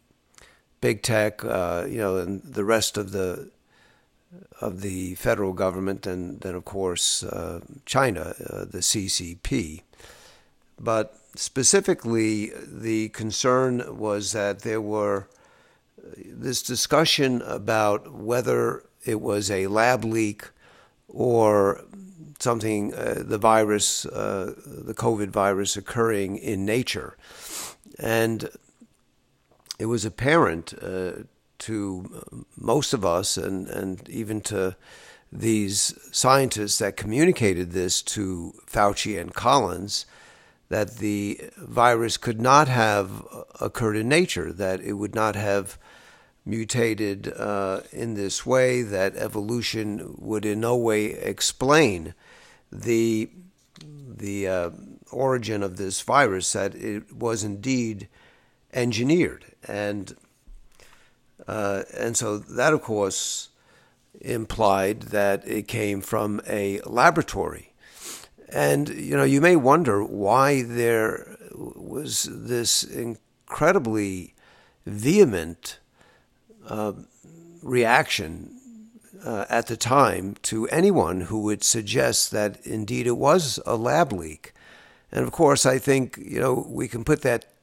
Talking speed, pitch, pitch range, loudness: 115 wpm, 110 Hz, 100-120 Hz, -24 LUFS